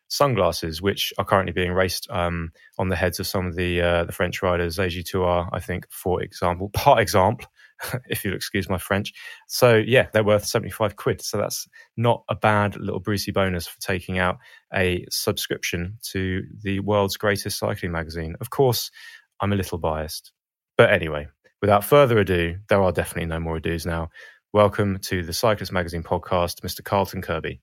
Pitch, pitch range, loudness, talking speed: 95 Hz, 85-100 Hz, -23 LUFS, 180 wpm